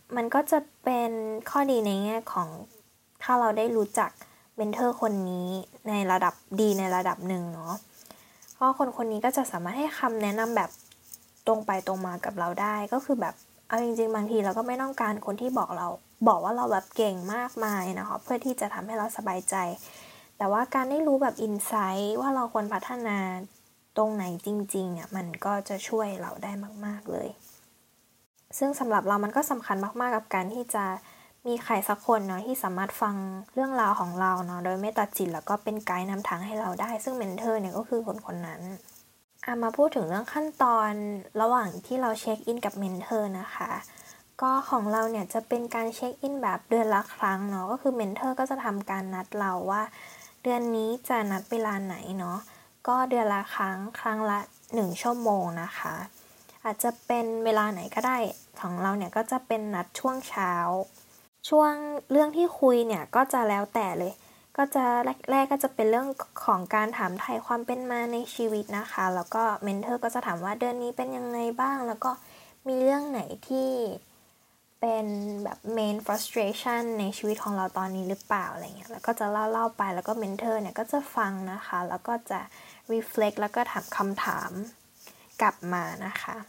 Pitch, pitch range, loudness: 220 Hz, 195-245 Hz, -29 LUFS